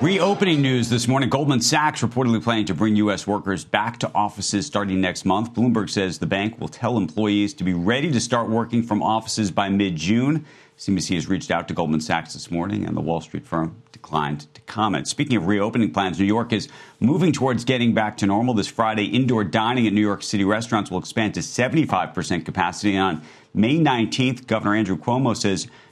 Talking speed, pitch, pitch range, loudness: 200 wpm, 105 Hz, 95-120 Hz, -22 LUFS